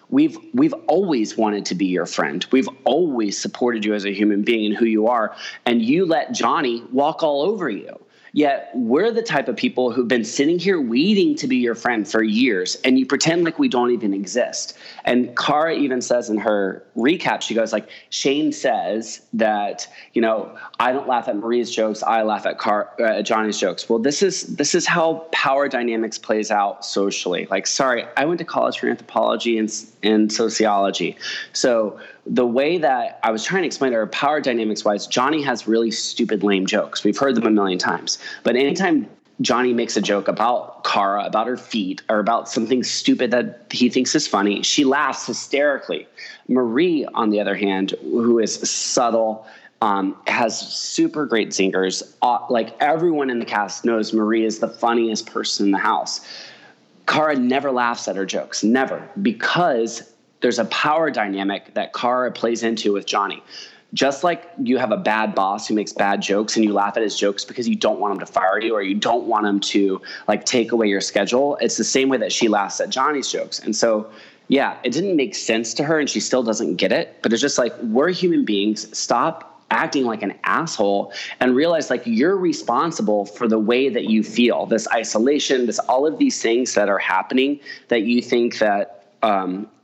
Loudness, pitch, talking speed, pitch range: -20 LUFS, 115 Hz, 200 wpm, 105-135 Hz